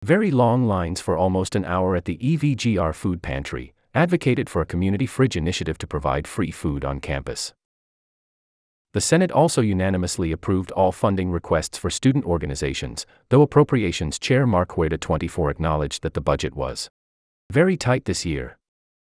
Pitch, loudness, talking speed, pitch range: 90 Hz, -22 LUFS, 160 wpm, 80-125 Hz